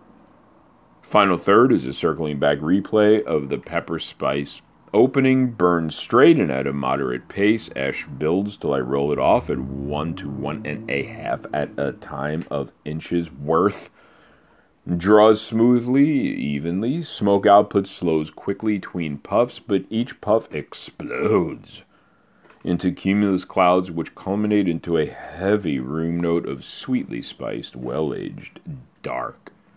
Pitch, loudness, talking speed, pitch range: 90 Hz, -21 LUFS, 135 wpm, 75-105 Hz